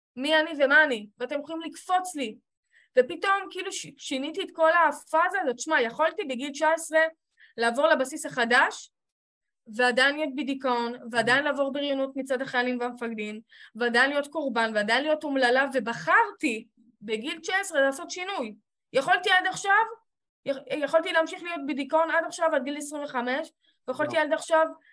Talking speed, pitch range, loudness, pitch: 140 wpm, 250-325 Hz, -26 LUFS, 290 Hz